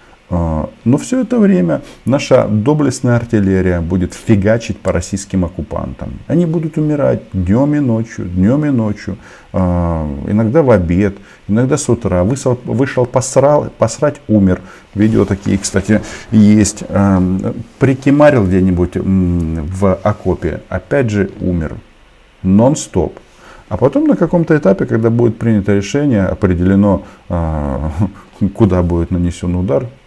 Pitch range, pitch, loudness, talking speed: 95-120 Hz, 100 Hz, -14 LUFS, 115 wpm